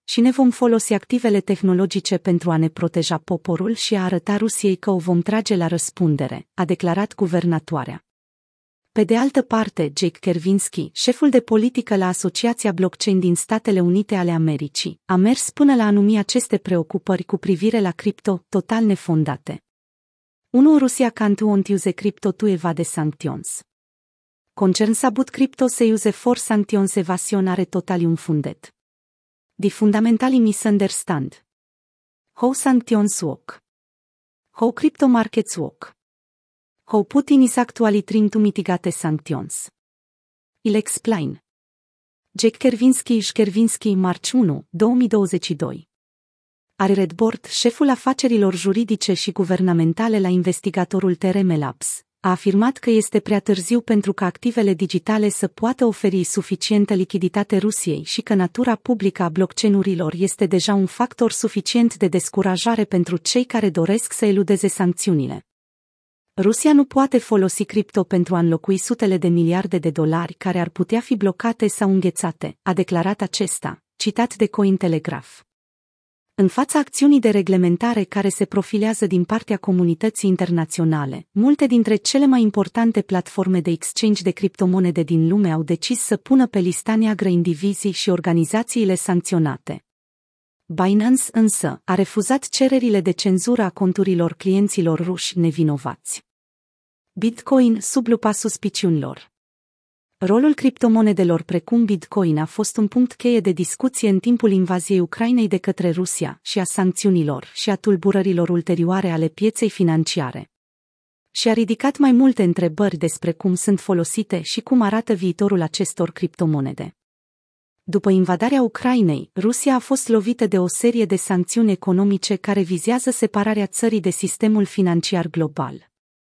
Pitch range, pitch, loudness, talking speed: 180-225 Hz, 200 Hz, -19 LUFS, 140 wpm